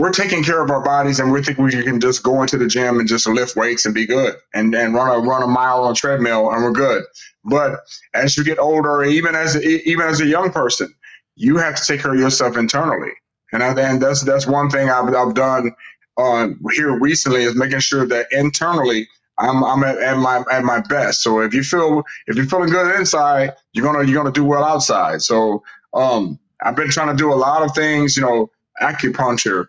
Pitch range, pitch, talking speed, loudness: 125-150 Hz, 135 Hz, 230 wpm, -16 LUFS